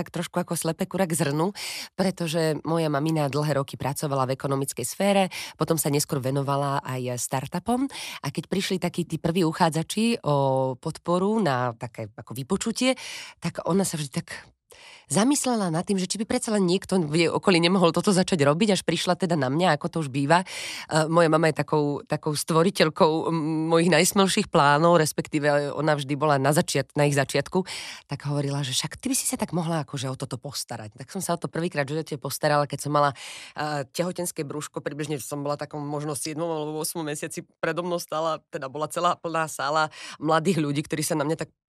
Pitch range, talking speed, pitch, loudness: 145-175 Hz, 195 wpm, 160 Hz, -25 LUFS